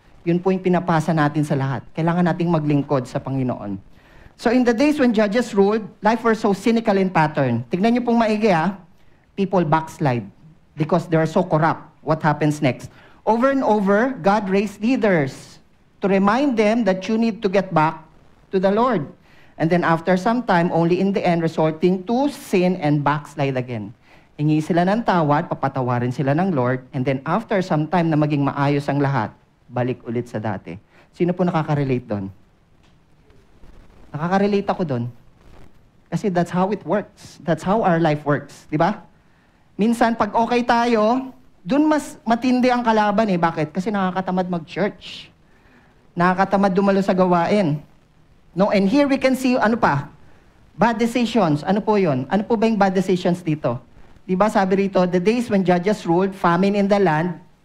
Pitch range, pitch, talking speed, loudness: 150-210 Hz, 180 Hz, 170 wpm, -20 LUFS